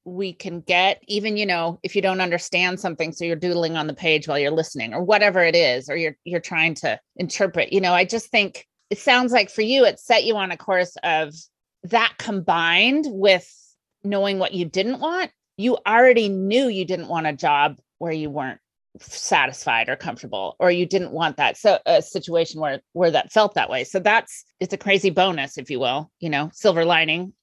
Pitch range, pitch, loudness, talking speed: 165-200 Hz, 180 Hz, -20 LUFS, 210 wpm